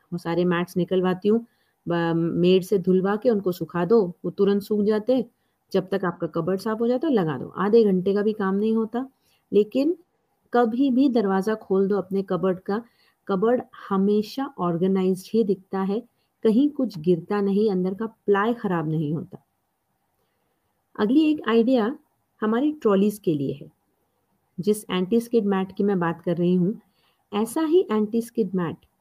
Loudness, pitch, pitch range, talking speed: -23 LUFS, 205 Hz, 185-230 Hz, 170 wpm